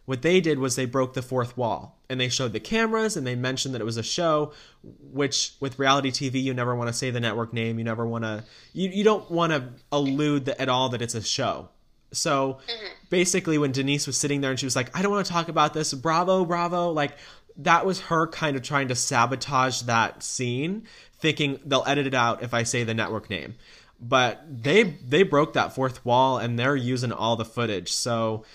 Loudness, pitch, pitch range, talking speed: -25 LUFS, 135 Hz, 125-155 Hz, 225 wpm